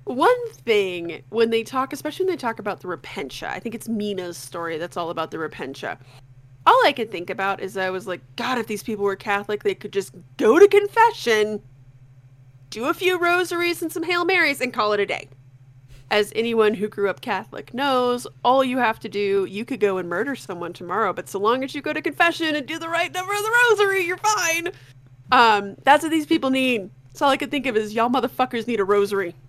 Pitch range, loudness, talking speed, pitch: 185-290 Hz, -21 LUFS, 220 wpm, 220 Hz